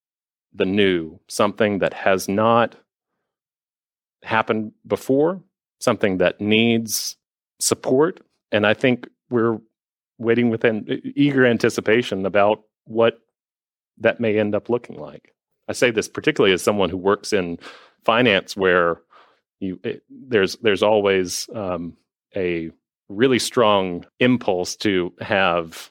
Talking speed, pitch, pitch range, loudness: 120 wpm, 105 Hz, 95-115 Hz, -20 LUFS